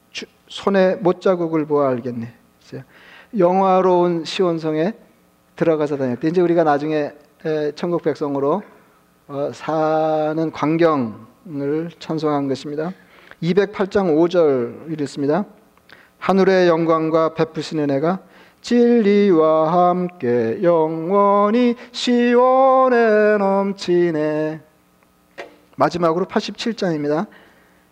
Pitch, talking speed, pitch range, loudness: 165 Hz, 200 characters per minute, 150-190 Hz, -18 LUFS